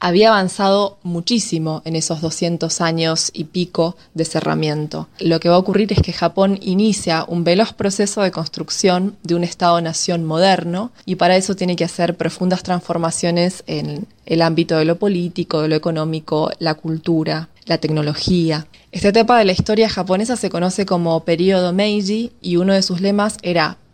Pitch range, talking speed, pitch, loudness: 165-195 Hz, 170 wpm, 175 Hz, -17 LUFS